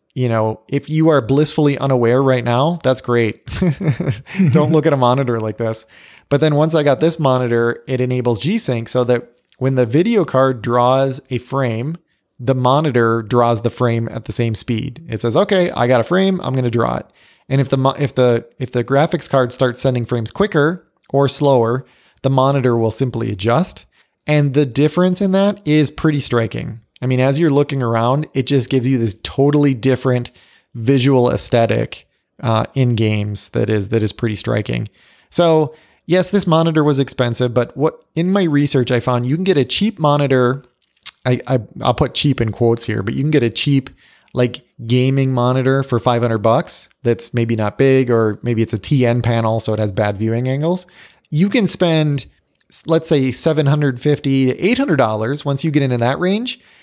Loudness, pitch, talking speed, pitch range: -16 LUFS, 130 Hz, 190 wpm, 120-150 Hz